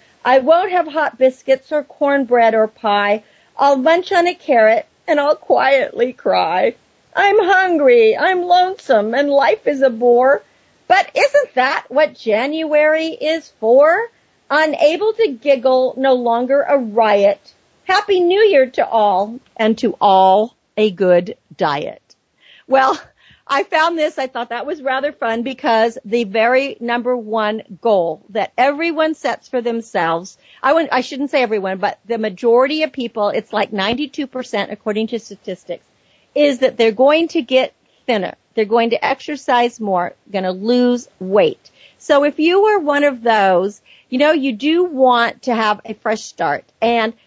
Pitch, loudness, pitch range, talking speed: 255 Hz, -16 LUFS, 220-300 Hz, 155 wpm